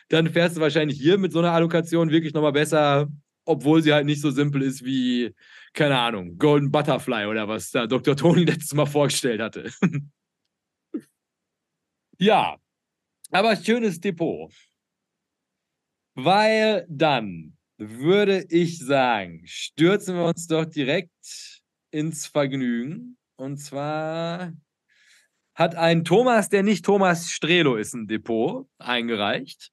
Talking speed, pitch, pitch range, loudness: 125 wpm, 155 Hz, 135-170 Hz, -22 LUFS